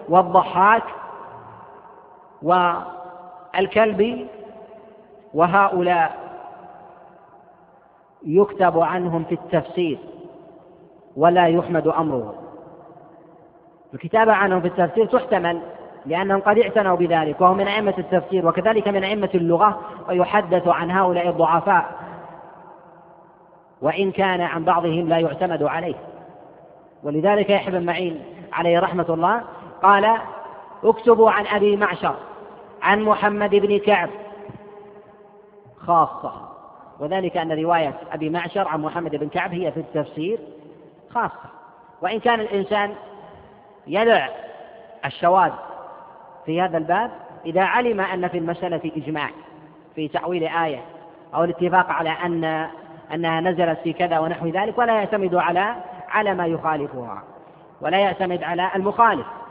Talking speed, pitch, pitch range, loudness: 105 wpm, 180 Hz, 170-205 Hz, -20 LUFS